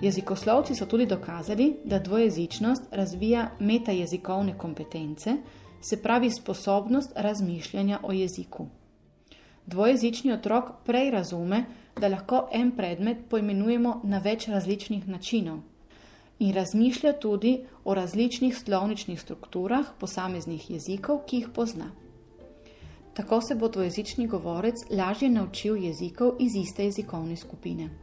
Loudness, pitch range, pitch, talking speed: -28 LUFS, 185-235 Hz, 205 Hz, 115 wpm